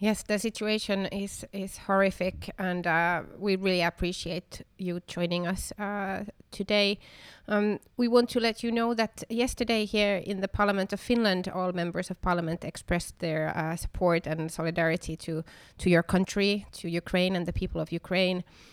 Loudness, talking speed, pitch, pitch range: -29 LUFS, 165 wpm, 185 Hz, 175-205 Hz